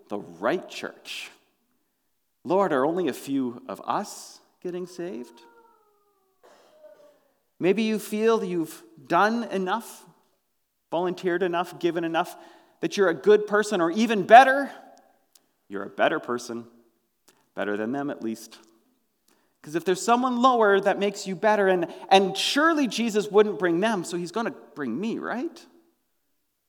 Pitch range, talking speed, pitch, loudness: 170-225 Hz, 140 wpm, 190 Hz, -24 LUFS